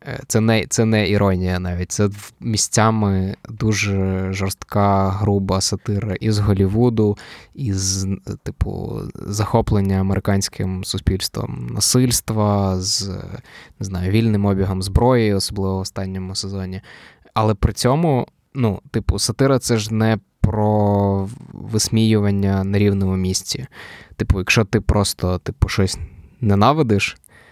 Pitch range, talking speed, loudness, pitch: 95-110 Hz, 110 wpm, -19 LUFS, 100 Hz